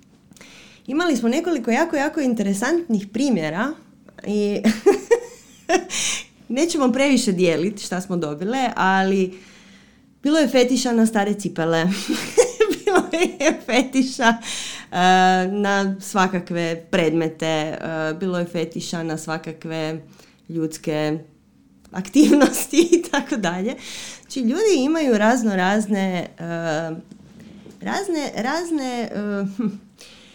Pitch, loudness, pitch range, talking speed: 210 Hz, -21 LUFS, 180-270 Hz, 95 wpm